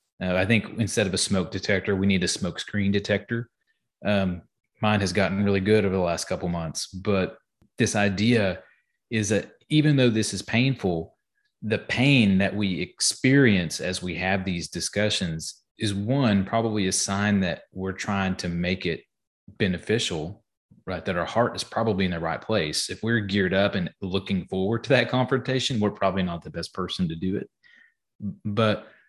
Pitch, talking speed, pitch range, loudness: 100 Hz, 180 wpm, 95-110 Hz, -25 LUFS